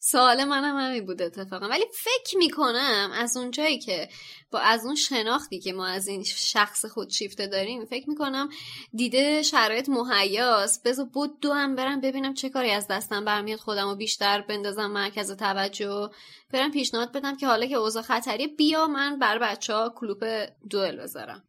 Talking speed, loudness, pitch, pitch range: 175 wpm, -25 LUFS, 230 Hz, 205-275 Hz